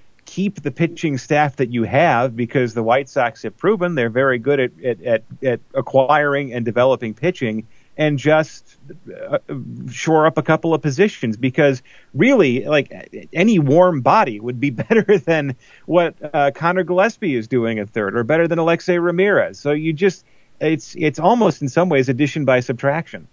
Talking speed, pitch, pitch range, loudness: 170 wpm, 150 Hz, 130-170 Hz, -18 LUFS